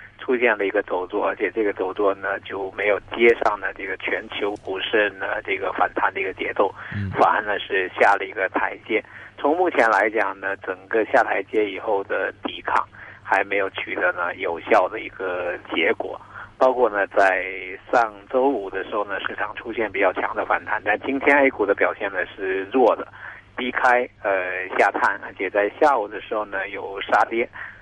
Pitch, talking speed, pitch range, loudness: 120 Hz, 270 characters per minute, 100-130 Hz, -22 LUFS